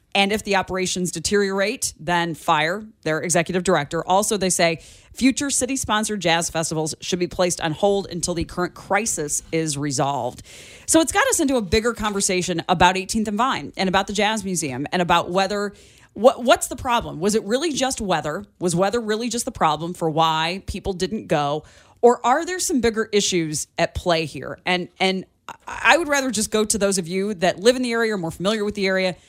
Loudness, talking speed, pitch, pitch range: -21 LUFS, 205 wpm, 190 Hz, 170-220 Hz